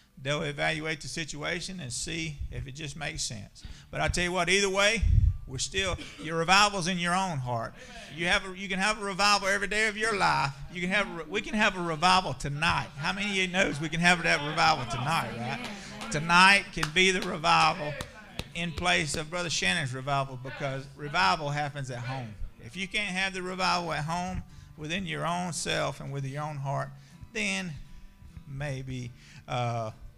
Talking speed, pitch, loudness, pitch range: 195 wpm, 160 Hz, -28 LUFS, 140-185 Hz